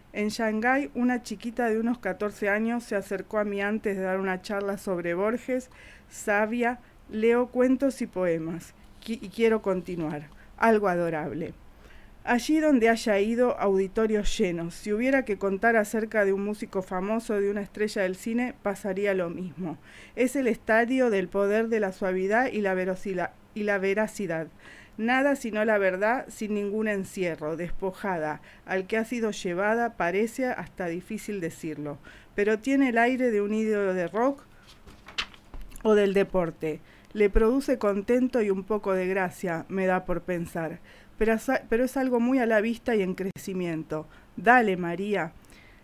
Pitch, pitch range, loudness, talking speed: 205 Hz, 185-230 Hz, -27 LUFS, 160 wpm